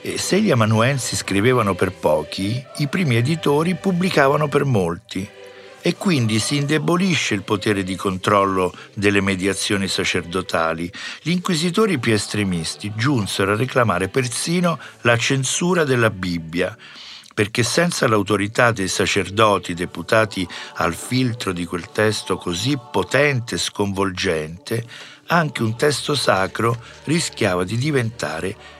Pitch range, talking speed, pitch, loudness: 95-145 Hz, 120 wpm, 110 Hz, -20 LUFS